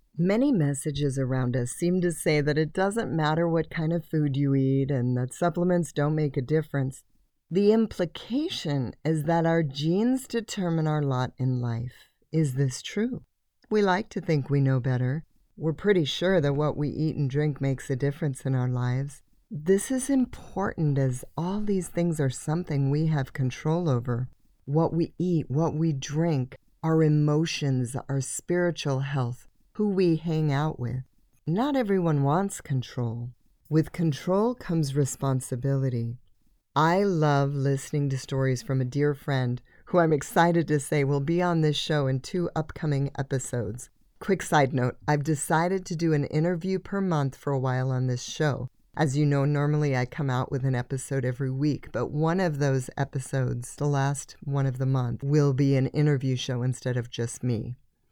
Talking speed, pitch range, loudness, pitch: 175 wpm, 130-165 Hz, -27 LUFS, 145 Hz